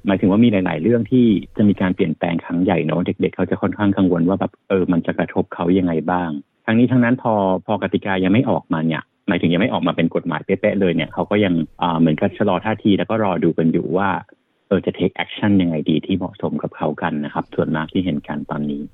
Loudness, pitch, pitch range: -19 LUFS, 95 Hz, 80-105 Hz